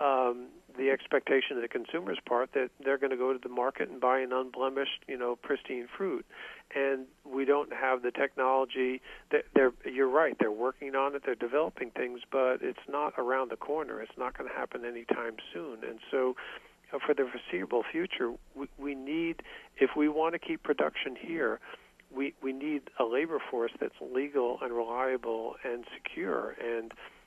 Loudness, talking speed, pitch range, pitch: -32 LUFS, 180 wpm, 130-145 Hz, 135 Hz